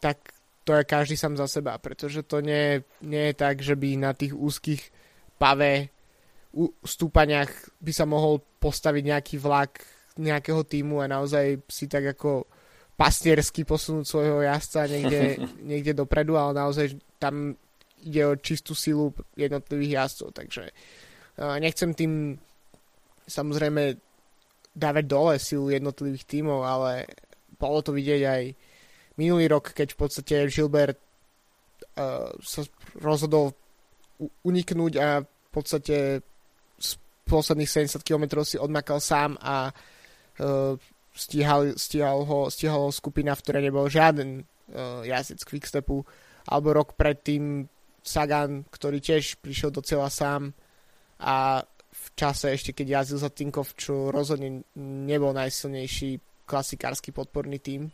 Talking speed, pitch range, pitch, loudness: 130 wpm, 140-150 Hz, 145 Hz, -26 LUFS